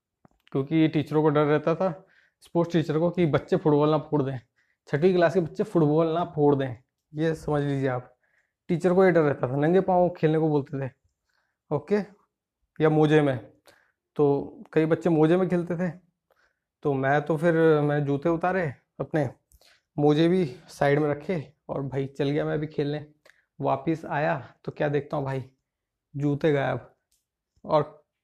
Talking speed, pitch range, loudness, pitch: 170 wpm, 145-170 Hz, -25 LUFS, 155 Hz